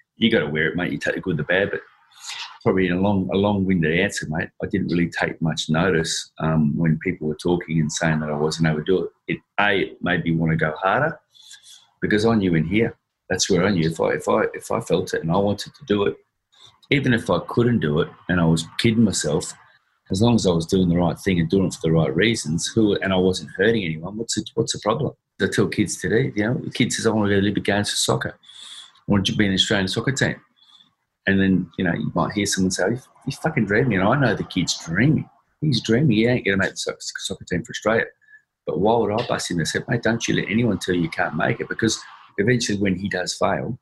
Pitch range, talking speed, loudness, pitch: 85-115 Hz, 260 wpm, -21 LUFS, 95 Hz